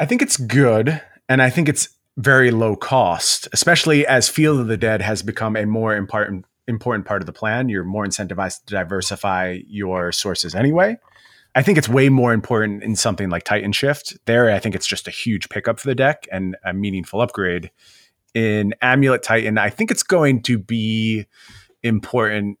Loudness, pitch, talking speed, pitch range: -18 LUFS, 110 Hz, 190 wpm, 100-130 Hz